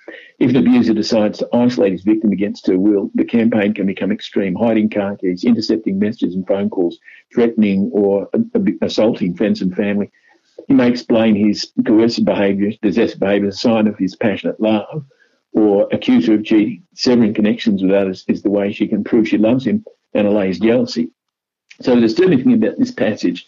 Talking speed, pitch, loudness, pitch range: 185 wpm, 110 Hz, -16 LUFS, 100-125 Hz